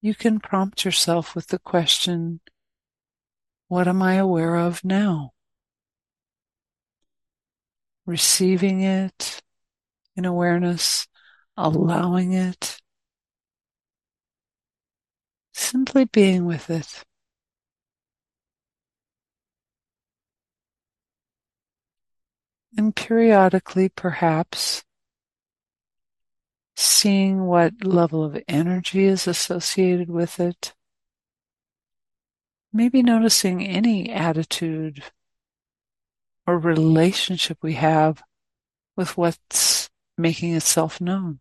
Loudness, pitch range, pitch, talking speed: -20 LUFS, 165-190 Hz, 180 Hz, 70 wpm